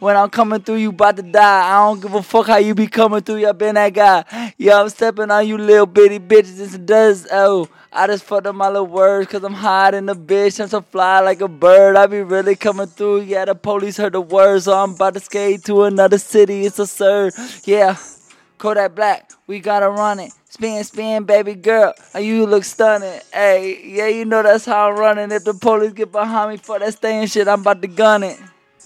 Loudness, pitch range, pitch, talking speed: -14 LUFS, 195-215 Hz, 205 Hz, 235 wpm